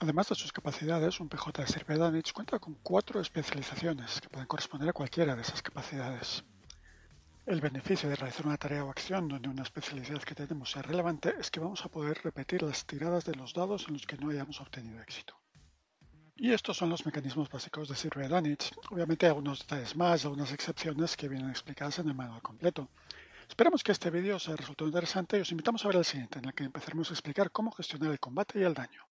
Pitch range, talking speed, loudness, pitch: 140-175 Hz, 215 wpm, -34 LUFS, 155 Hz